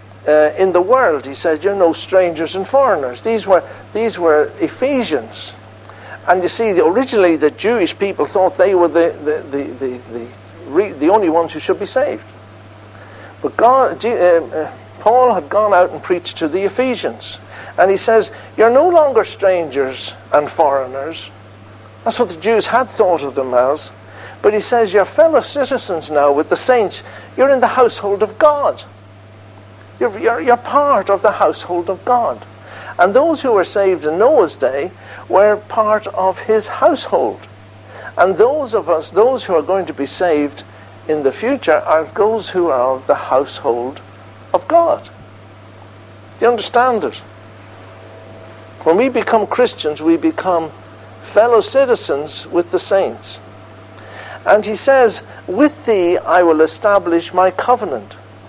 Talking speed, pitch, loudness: 160 wpm, 170 Hz, -15 LUFS